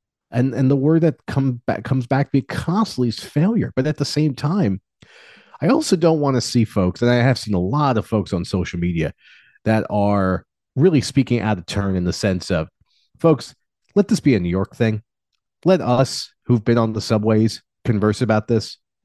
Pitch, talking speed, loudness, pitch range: 120 Hz, 210 wpm, -19 LUFS, 105-145 Hz